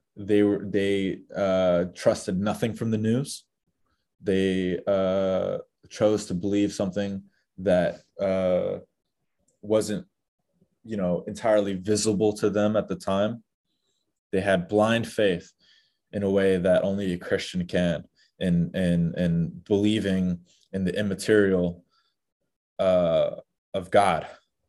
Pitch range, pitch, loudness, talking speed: 90-105 Hz, 100 Hz, -25 LUFS, 120 wpm